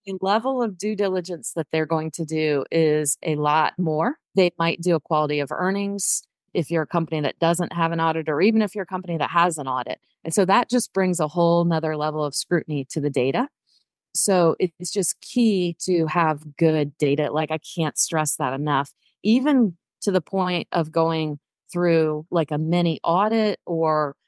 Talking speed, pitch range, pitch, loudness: 200 wpm, 155-185 Hz, 165 Hz, -22 LUFS